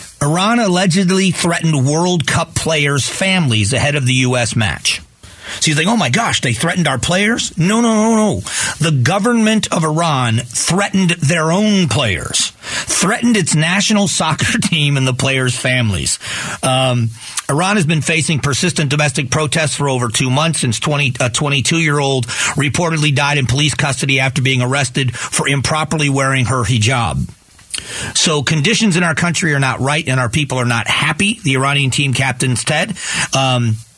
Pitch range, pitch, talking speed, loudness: 130-170 Hz, 145 Hz, 165 wpm, -14 LUFS